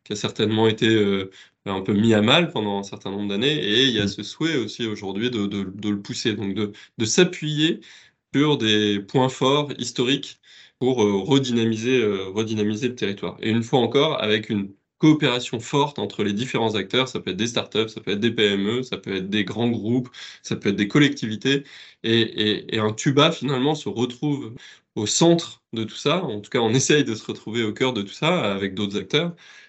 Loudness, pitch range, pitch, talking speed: -22 LUFS, 105-130 Hz, 115 Hz, 215 wpm